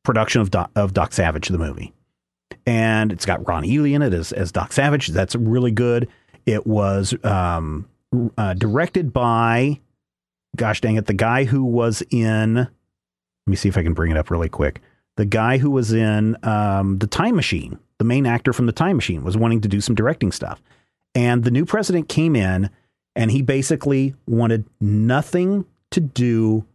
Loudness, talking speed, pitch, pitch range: -20 LUFS, 185 wpm, 110 Hz, 95-125 Hz